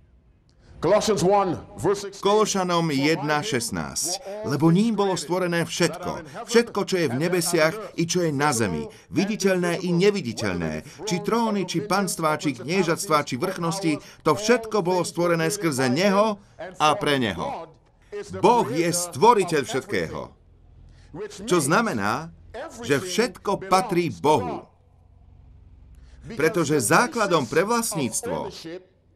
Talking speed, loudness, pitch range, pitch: 105 wpm, -23 LUFS, 145-195 Hz, 170 Hz